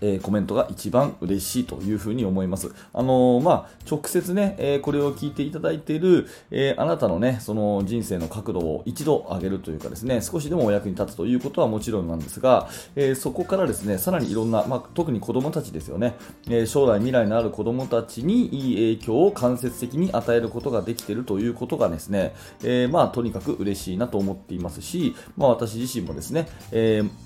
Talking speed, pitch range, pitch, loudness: 440 characters per minute, 100-130 Hz, 115 Hz, -24 LUFS